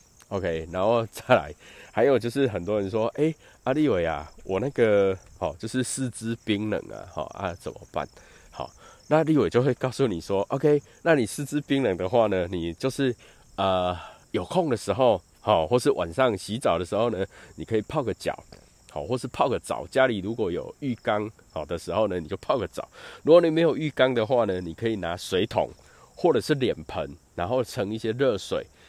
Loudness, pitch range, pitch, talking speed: -26 LUFS, 95-130 Hz, 115 Hz, 290 characters per minute